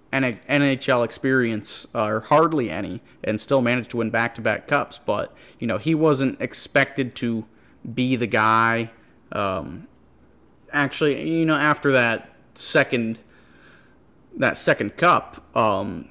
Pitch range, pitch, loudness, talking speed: 115-140 Hz, 125 Hz, -22 LUFS, 125 wpm